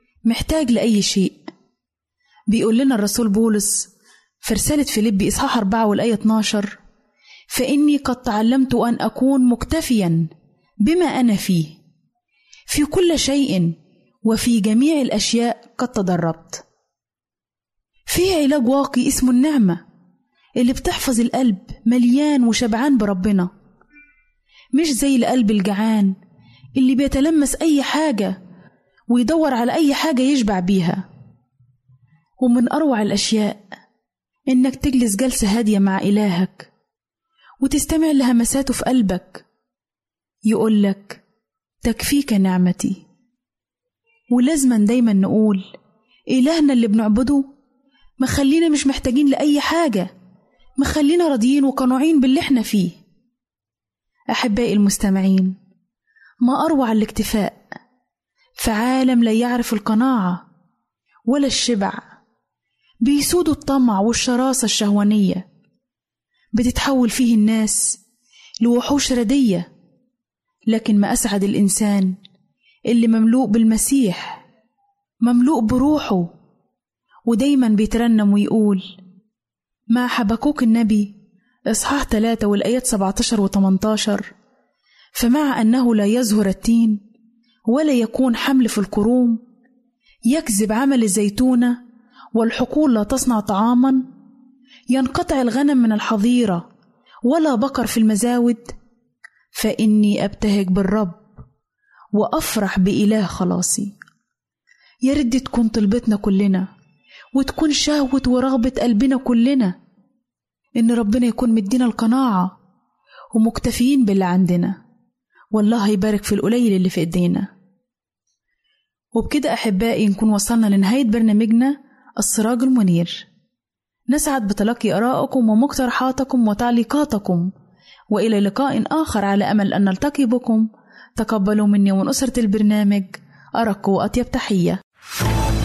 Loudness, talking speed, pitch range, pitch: -18 LUFS, 95 wpm, 205-260 Hz, 230 Hz